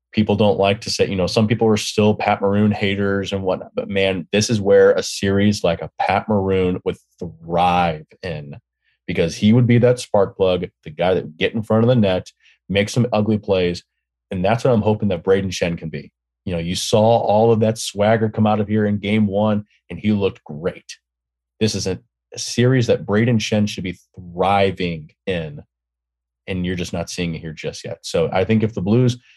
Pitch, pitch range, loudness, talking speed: 100 Hz, 90-110 Hz, -19 LUFS, 215 wpm